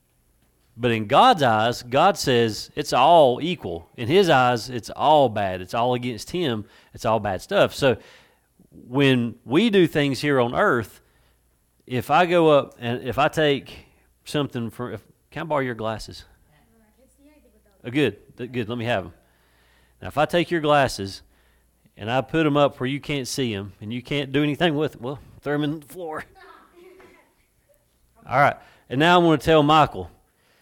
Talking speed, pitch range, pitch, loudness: 180 wpm, 110-150 Hz, 125 Hz, -21 LUFS